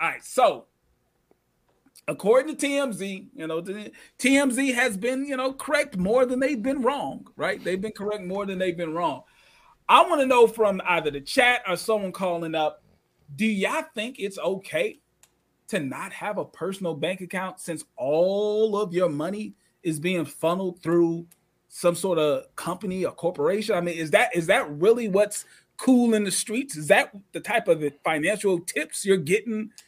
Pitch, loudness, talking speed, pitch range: 195 Hz, -24 LUFS, 180 wpm, 175-230 Hz